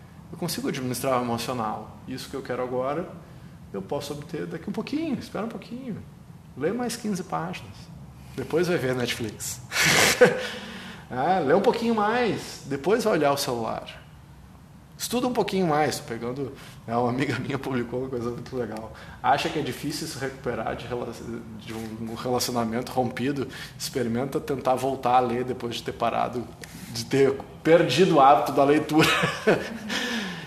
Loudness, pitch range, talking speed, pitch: -25 LUFS, 125-170 Hz, 160 wpm, 140 Hz